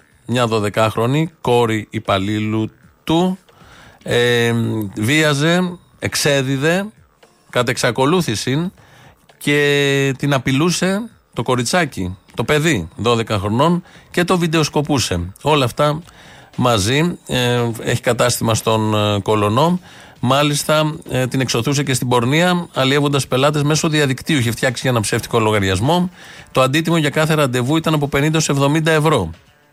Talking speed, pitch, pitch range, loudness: 110 wpm, 140 Hz, 115-155 Hz, -17 LUFS